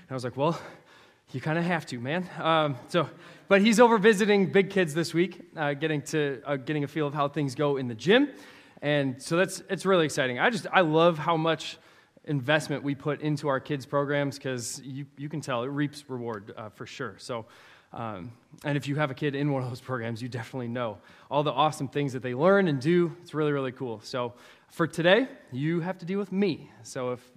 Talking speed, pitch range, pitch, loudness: 230 wpm, 135-170 Hz, 150 Hz, -27 LUFS